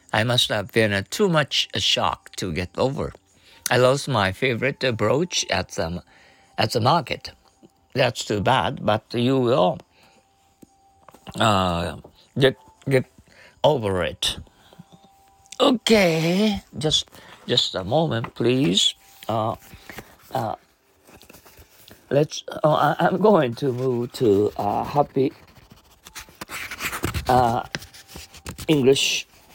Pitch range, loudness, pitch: 100-150 Hz, -22 LUFS, 125 Hz